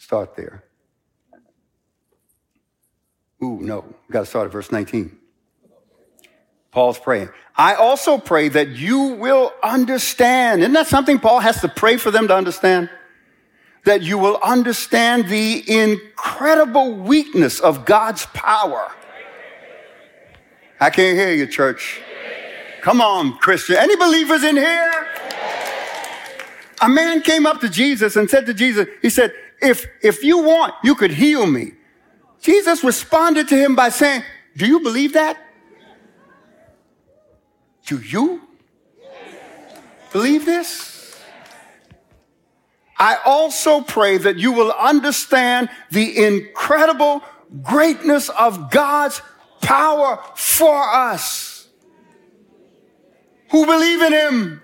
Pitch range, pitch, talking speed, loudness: 220-310 Hz, 275 Hz, 115 wpm, -16 LUFS